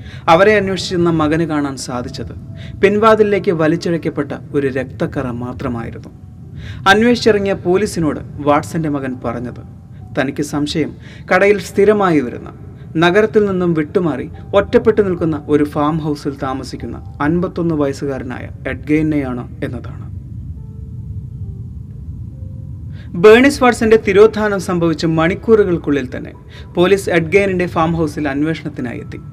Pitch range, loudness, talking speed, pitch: 125-180 Hz, -15 LUFS, 90 wpm, 150 Hz